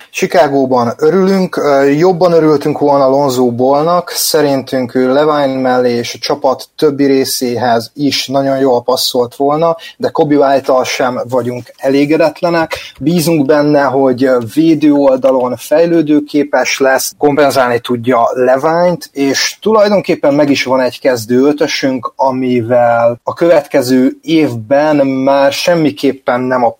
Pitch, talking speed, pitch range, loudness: 140 Hz, 120 wpm, 130-155 Hz, -11 LUFS